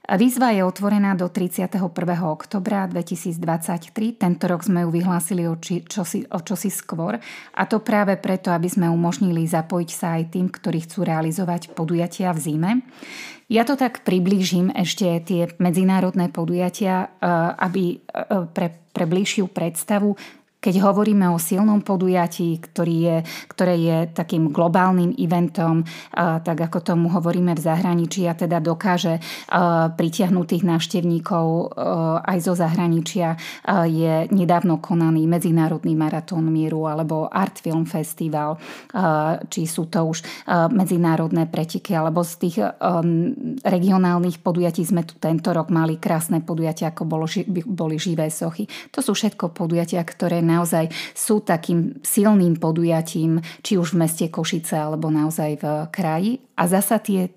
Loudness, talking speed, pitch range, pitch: -21 LUFS, 135 wpm, 165-190 Hz, 175 Hz